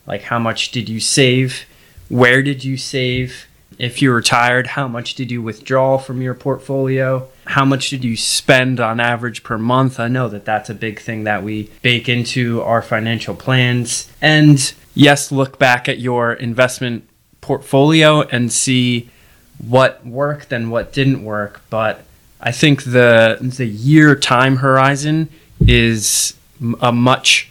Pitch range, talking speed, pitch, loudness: 115-135 Hz, 155 wpm, 125 Hz, -15 LUFS